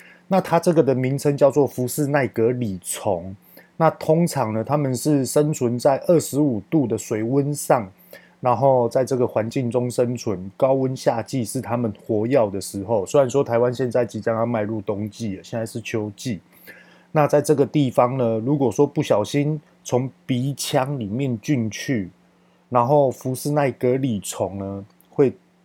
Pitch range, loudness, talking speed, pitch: 115-145 Hz, -21 LUFS, 245 characters per minute, 130 Hz